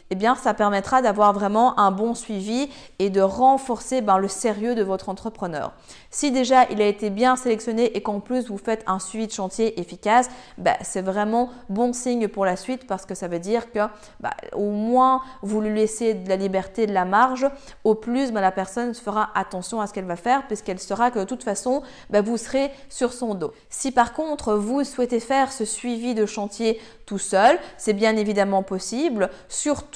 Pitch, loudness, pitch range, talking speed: 220 Hz, -23 LUFS, 200-250 Hz, 205 wpm